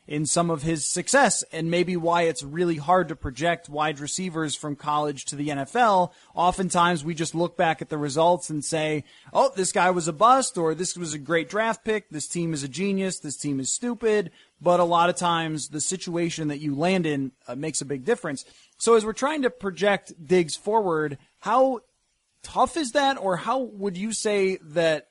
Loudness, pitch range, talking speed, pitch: -24 LUFS, 155-195 Hz, 205 wpm, 170 Hz